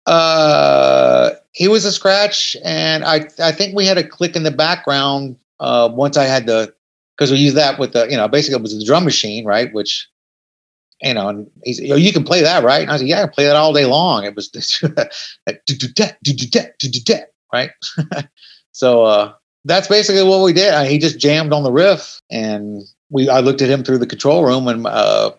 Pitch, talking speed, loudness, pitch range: 140 Hz, 210 wpm, -14 LUFS, 125-160 Hz